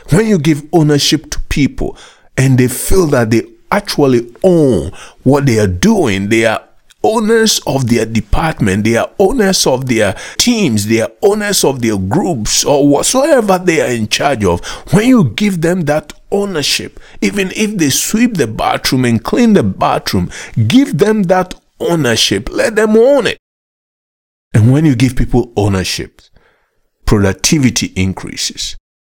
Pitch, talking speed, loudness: 135 Hz, 155 wpm, -12 LUFS